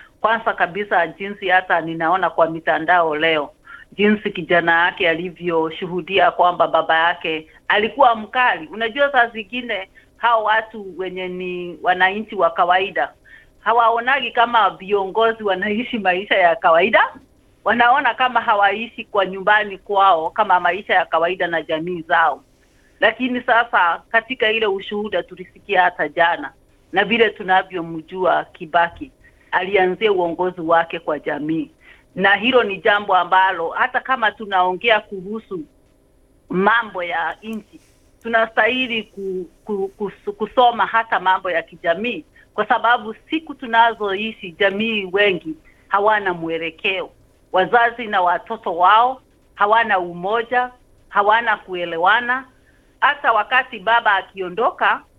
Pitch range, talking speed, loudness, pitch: 180-230 Hz, 115 wpm, -18 LUFS, 205 Hz